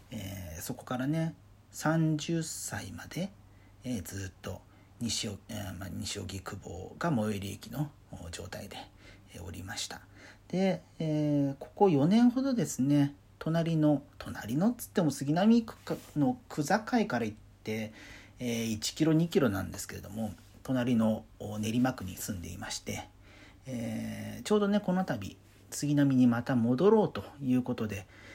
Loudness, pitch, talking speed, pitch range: -31 LUFS, 110 Hz, 260 characters per minute, 100-145 Hz